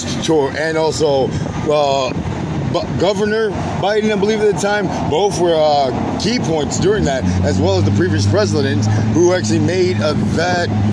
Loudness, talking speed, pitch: -16 LUFS, 165 wpm, 140 Hz